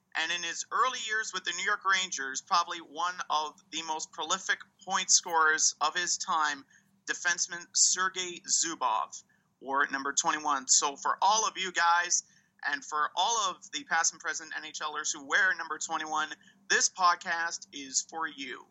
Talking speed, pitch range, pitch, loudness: 170 wpm, 155-185 Hz, 170 Hz, -29 LUFS